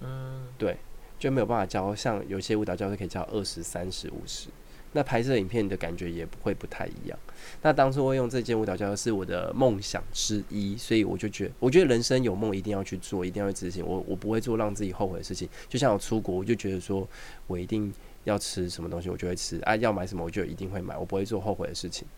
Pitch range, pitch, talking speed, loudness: 90-115 Hz, 100 Hz, 370 characters per minute, -29 LUFS